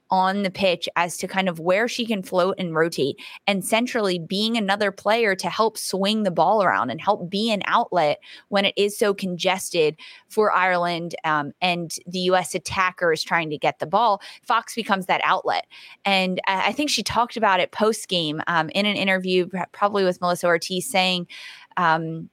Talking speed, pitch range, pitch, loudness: 190 wpm, 175-205 Hz, 190 Hz, -22 LUFS